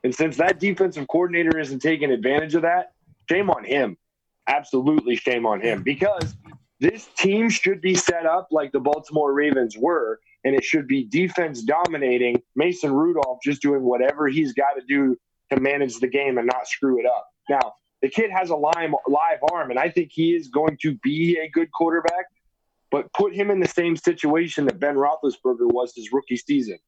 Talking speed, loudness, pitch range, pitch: 190 wpm, -22 LUFS, 140-185 Hz, 160 Hz